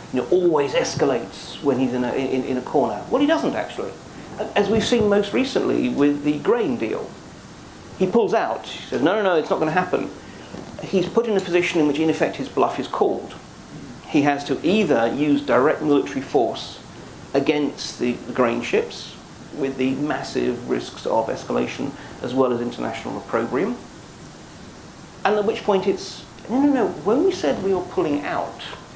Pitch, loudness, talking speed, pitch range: 175 Hz, -22 LUFS, 185 wpm, 140-230 Hz